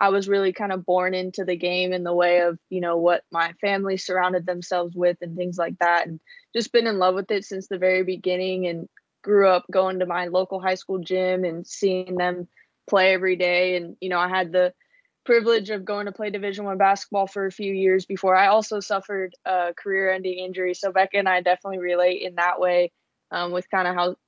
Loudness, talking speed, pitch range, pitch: -23 LUFS, 225 wpm, 180-195 Hz, 185 Hz